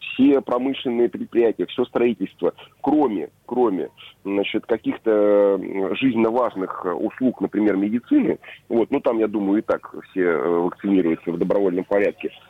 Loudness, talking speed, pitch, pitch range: -21 LUFS, 125 wpm, 110 Hz, 100-130 Hz